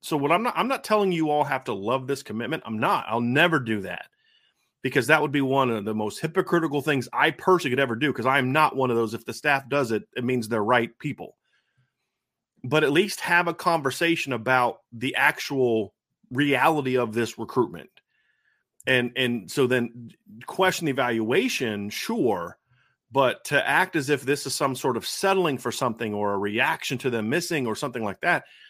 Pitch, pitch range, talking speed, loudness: 135 Hz, 120-155 Hz, 200 wpm, -24 LUFS